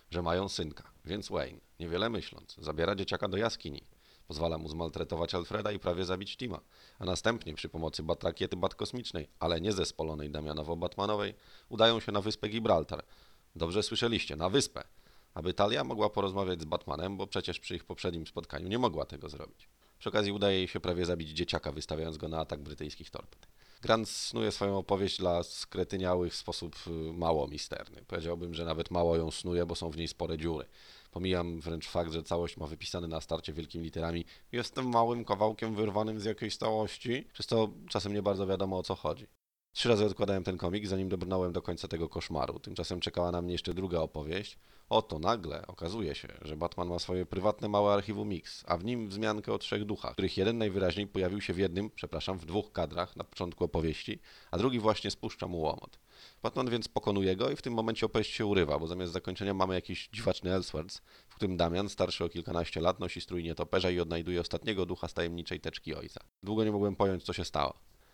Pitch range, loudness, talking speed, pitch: 85-105 Hz, -34 LUFS, 190 wpm, 90 Hz